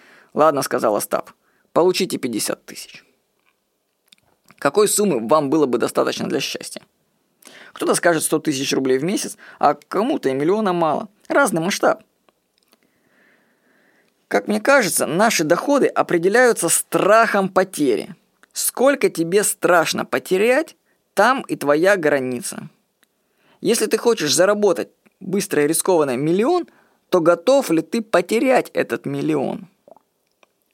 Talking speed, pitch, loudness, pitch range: 115 wpm, 195 Hz, -18 LUFS, 165-225 Hz